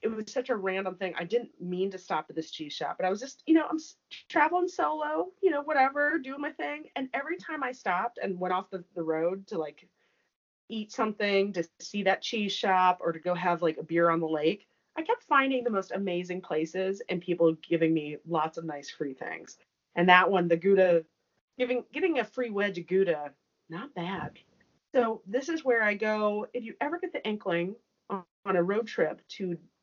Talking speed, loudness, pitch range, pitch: 215 wpm, -29 LUFS, 175-250 Hz, 195 Hz